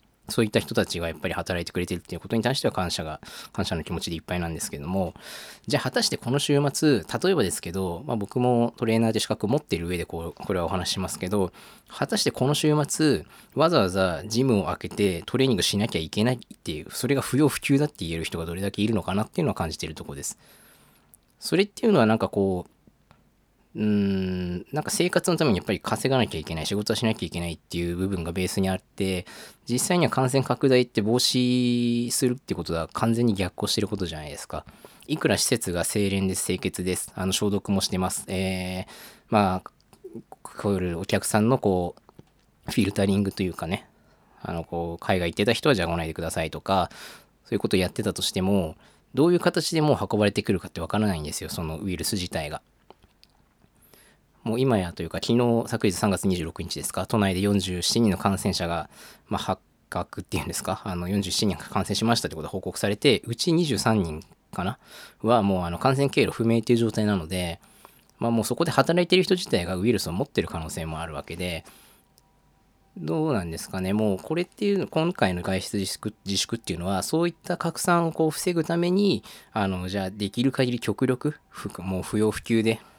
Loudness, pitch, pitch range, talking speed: -25 LUFS, 100 Hz, 90-125 Hz, 425 characters per minute